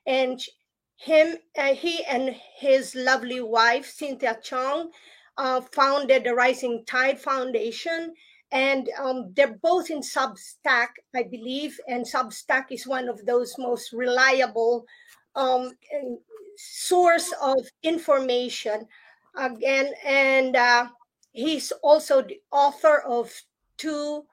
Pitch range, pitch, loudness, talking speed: 245-295 Hz, 265 Hz, -24 LUFS, 110 wpm